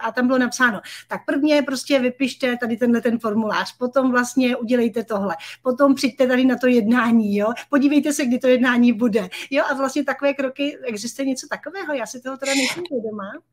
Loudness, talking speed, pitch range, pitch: -20 LUFS, 190 wpm, 235-275 Hz, 255 Hz